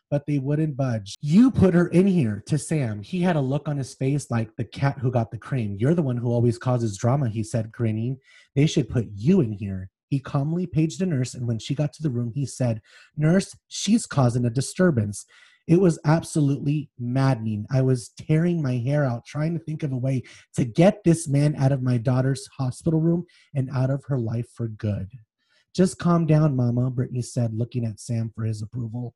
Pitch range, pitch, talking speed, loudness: 120-155 Hz, 135 Hz, 215 wpm, -24 LUFS